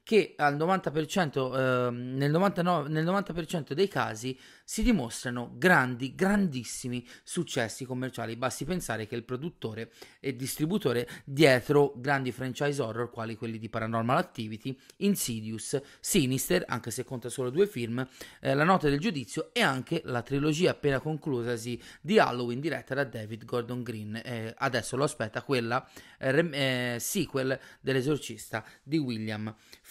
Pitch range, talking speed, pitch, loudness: 120-155 Hz, 135 wpm, 130 Hz, -30 LUFS